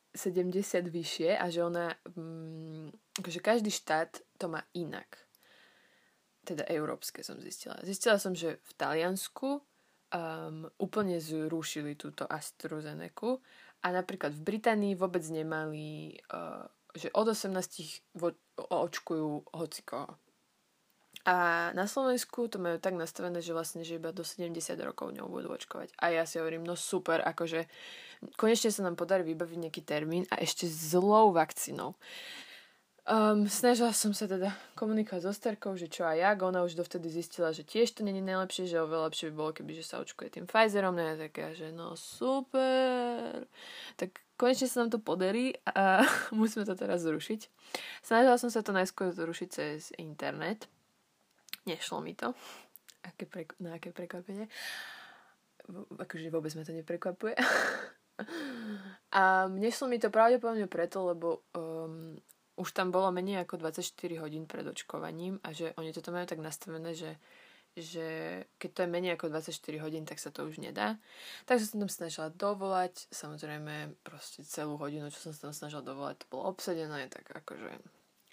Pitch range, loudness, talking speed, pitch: 165-205 Hz, -34 LUFS, 150 wpm, 180 Hz